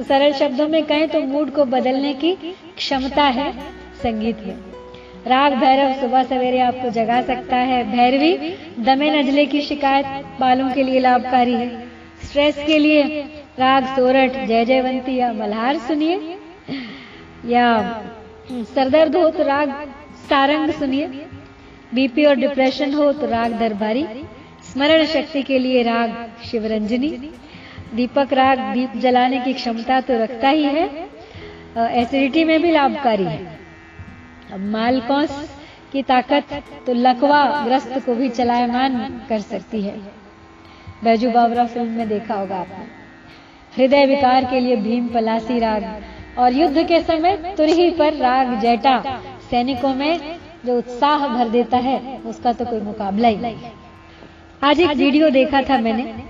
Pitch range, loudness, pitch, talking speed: 240-285 Hz, -18 LUFS, 260 Hz, 140 wpm